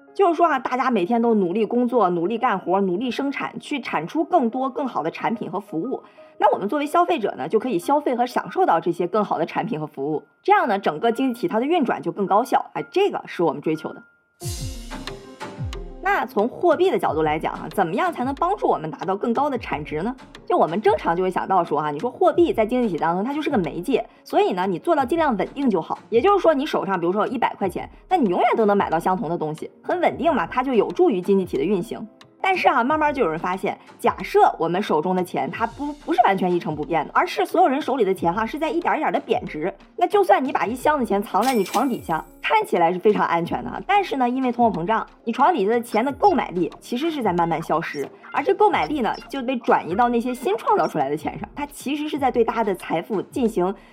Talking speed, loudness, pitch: 370 characters per minute, -22 LUFS, 245 Hz